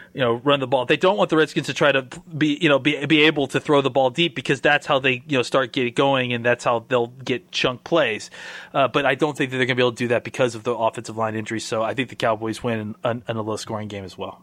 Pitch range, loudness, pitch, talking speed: 115-145 Hz, -21 LUFS, 130 Hz, 305 wpm